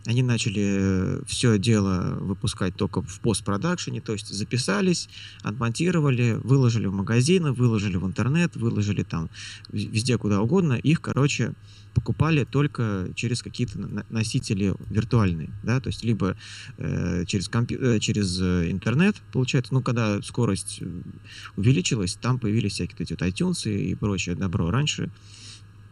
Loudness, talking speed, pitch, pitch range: -25 LUFS, 130 wpm, 110 Hz, 100-125 Hz